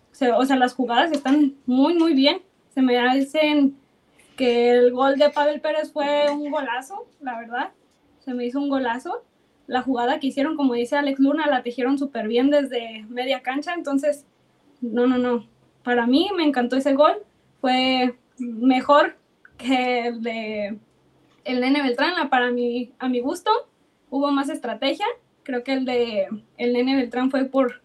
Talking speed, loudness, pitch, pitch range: 170 wpm, -22 LUFS, 265 Hz, 245-290 Hz